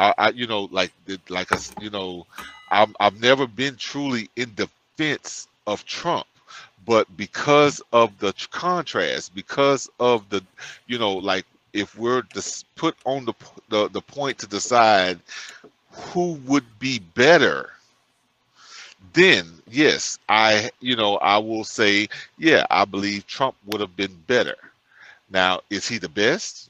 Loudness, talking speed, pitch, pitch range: -21 LUFS, 145 wpm, 110 Hz, 100-130 Hz